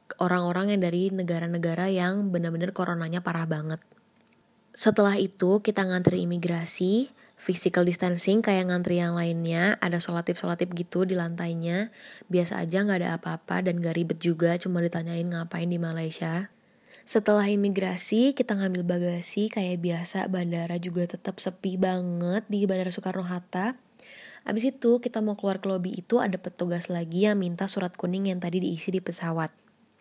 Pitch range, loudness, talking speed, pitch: 175-200 Hz, -27 LUFS, 150 wpm, 180 Hz